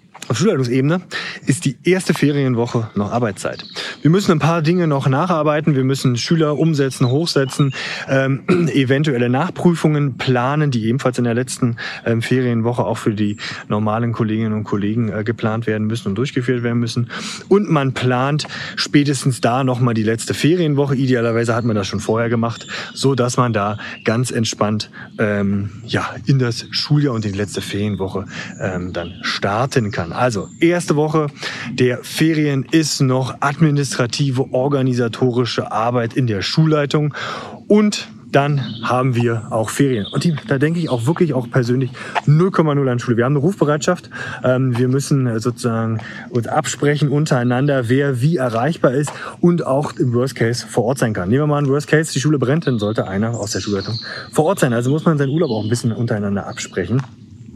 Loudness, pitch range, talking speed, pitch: -18 LUFS, 115-145 Hz, 170 wpm, 130 Hz